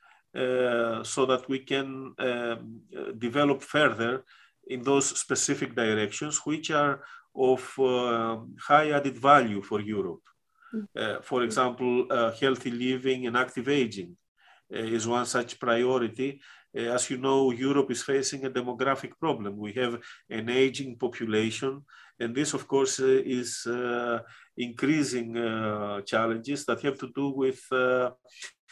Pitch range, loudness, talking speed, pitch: 115-135 Hz, -28 LUFS, 135 wpm, 125 Hz